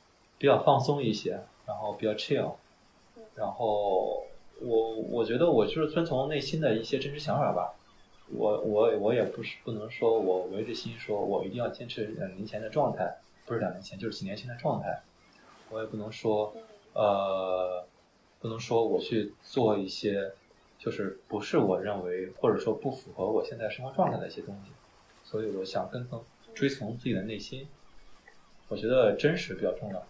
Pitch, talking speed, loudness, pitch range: 110 Hz, 270 characters per minute, -31 LUFS, 100-135 Hz